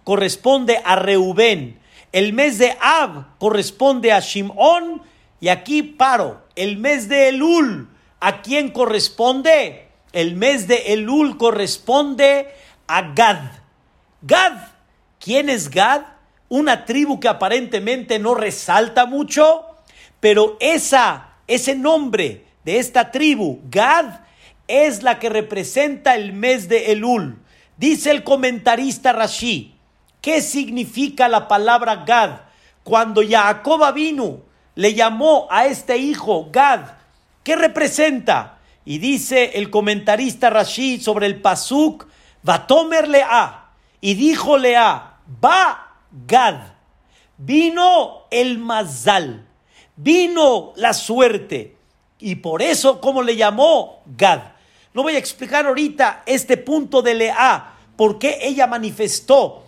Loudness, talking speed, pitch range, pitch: -16 LUFS, 115 wpm, 215-285 Hz, 250 Hz